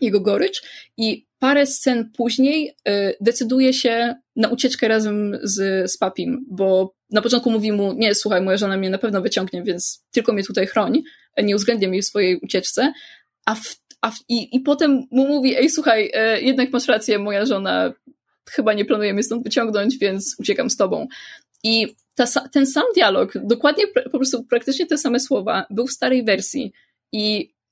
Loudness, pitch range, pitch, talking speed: -19 LUFS, 205-265 Hz, 235 Hz, 180 wpm